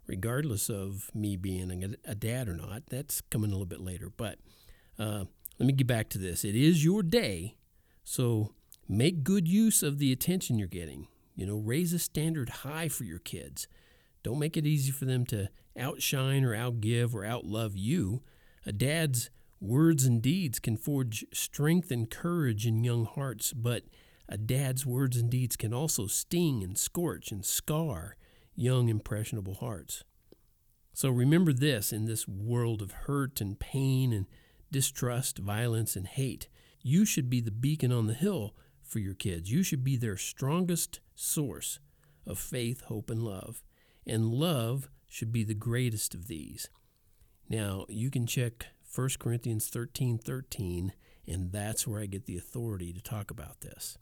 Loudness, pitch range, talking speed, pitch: -32 LUFS, 105-135 Hz, 170 wpm, 120 Hz